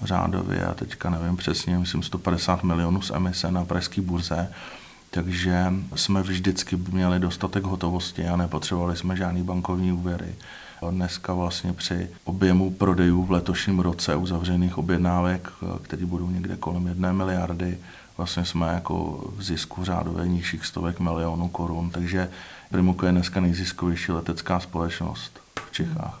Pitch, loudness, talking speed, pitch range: 90 Hz, -26 LUFS, 135 wpm, 85-90 Hz